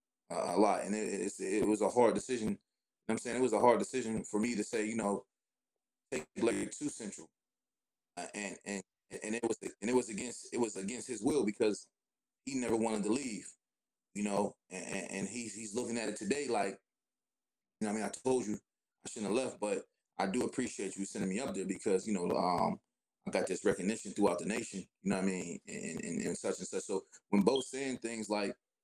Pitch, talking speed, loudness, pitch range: 110 Hz, 235 wpm, -36 LUFS, 105-125 Hz